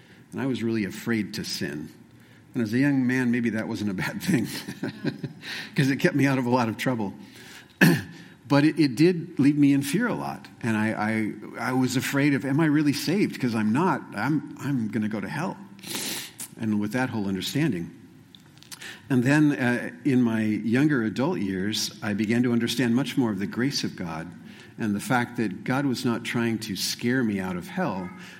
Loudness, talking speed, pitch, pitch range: -25 LUFS, 205 wpm, 120 Hz, 110-135 Hz